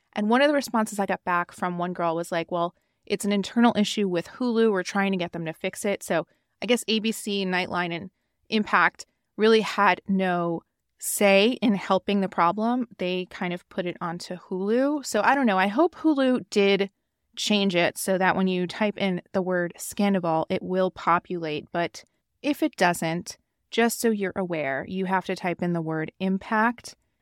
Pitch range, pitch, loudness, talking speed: 175-215 Hz, 190 Hz, -25 LUFS, 195 wpm